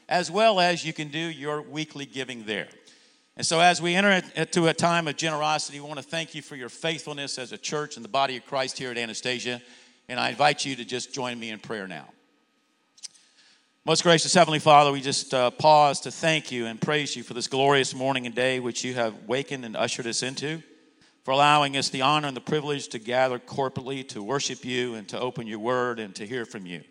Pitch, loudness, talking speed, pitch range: 135 Hz, -25 LUFS, 225 wpm, 125-155 Hz